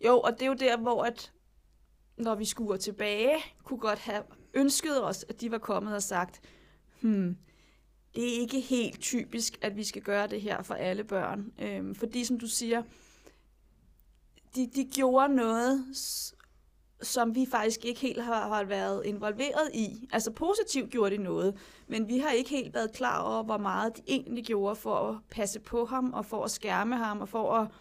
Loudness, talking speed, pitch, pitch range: -31 LUFS, 190 wpm, 225 Hz, 210-250 Hz